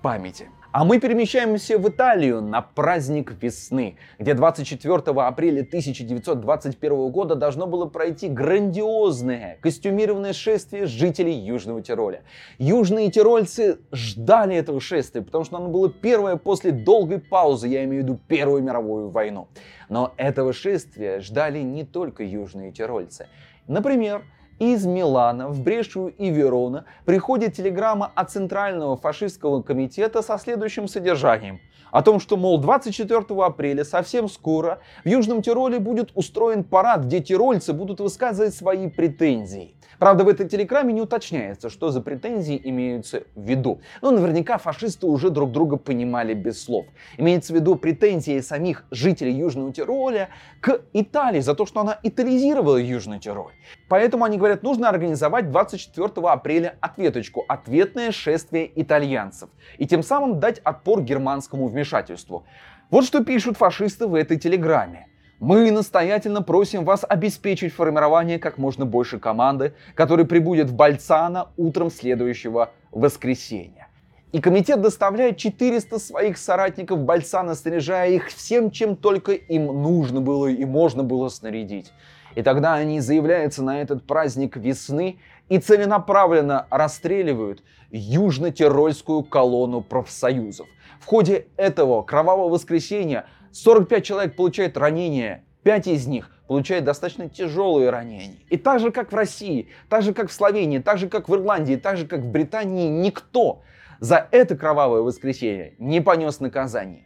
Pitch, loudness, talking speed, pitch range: 170 Hz, -21 LUFS, 135 wpm, 140-205 Hz